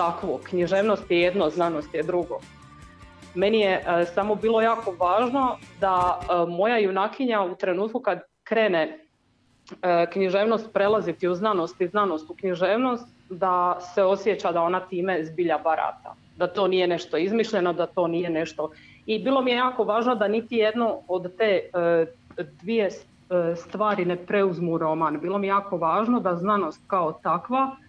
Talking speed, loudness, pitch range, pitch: 160 wpm, -24 LUFS, 175-210 Hz, 185 Hz